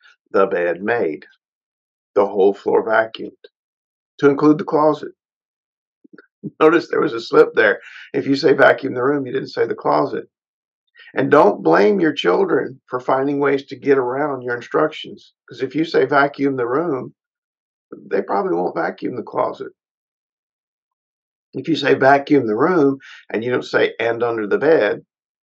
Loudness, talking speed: -18 LUFS, 160 wpm